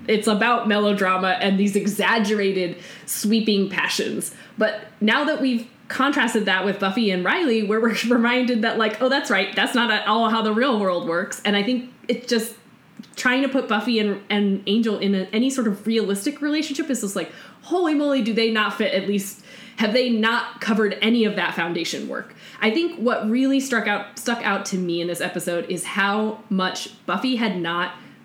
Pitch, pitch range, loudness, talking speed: 220 Hz, 195-235 Hz, -21 LUFS, 200 wpm